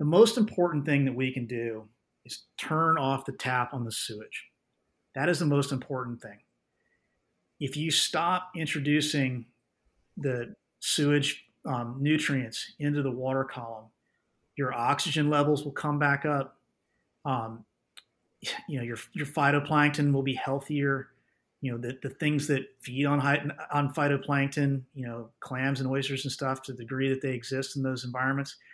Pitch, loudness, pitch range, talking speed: 135 Hz, -29 LUFS, 130-145 Hz, 160 wpm